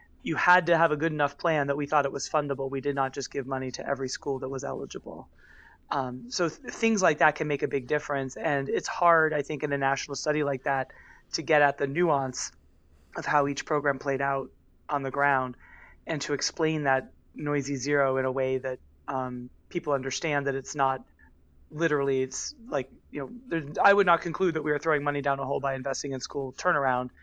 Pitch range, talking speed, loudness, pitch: 135-150 Hz, 220 wpm, -28 LUFS, 140 Hz